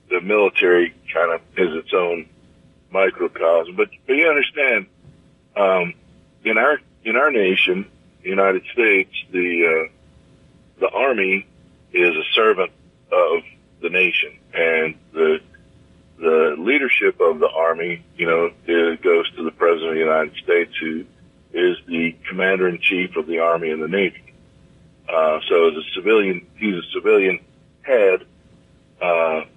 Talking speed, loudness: 145 wpm, -19 LUFS